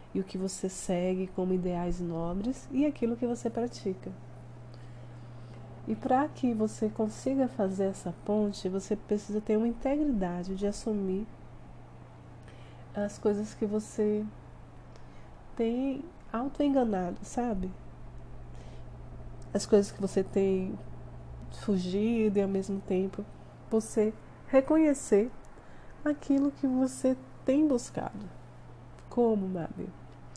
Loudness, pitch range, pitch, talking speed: -31 LUFS, 180-235 Hz, 205 Hz, 105 wpm